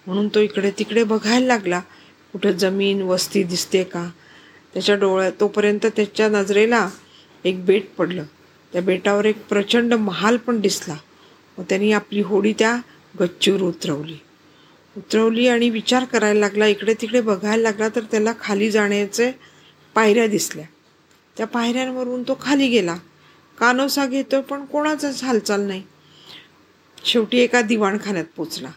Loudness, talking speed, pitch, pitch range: -19 LUFS, 130 wpm, 210 Hz, 195-235 Hz